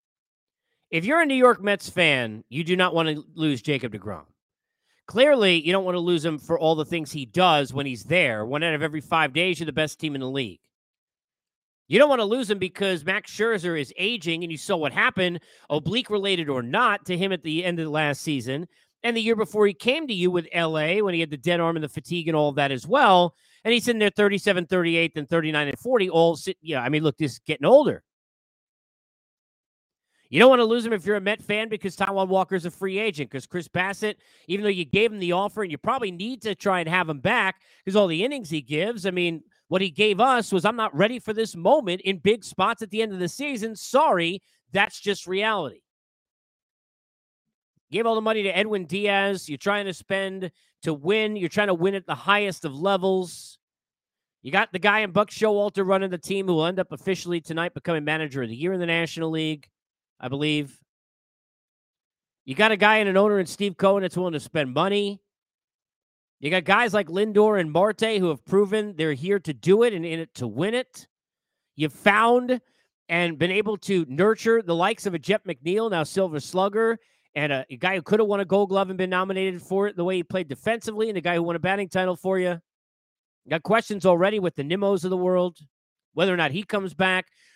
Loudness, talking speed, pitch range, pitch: -23 LUFS, 230 wpm, 160-205 Hz, 185 Hz